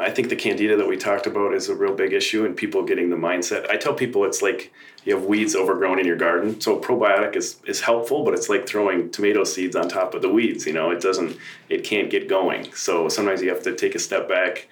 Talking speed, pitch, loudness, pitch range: 255 wpm, 390 Hz, -22 LUFS, 380-410 Hz